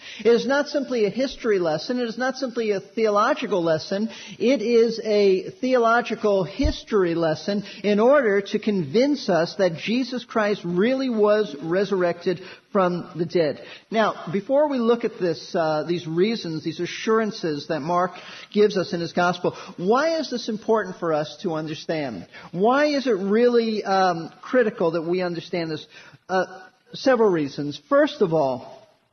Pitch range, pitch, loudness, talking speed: 175-230 Hz, 200 Hz, -23 LUFS, 155 wpm